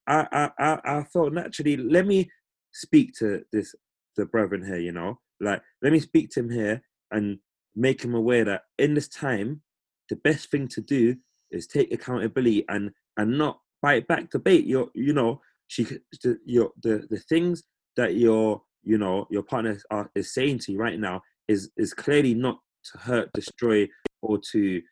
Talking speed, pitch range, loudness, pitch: 185 wpm, 105-145 Hz, -25 LUFS, 120 Hz